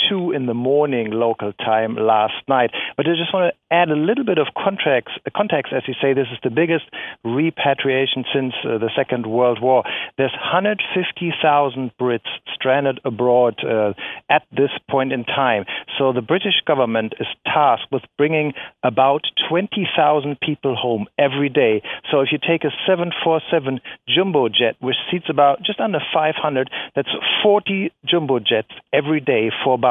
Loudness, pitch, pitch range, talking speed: -19 LUFS, 135 Hz, 125-160 Hz, 160 wpm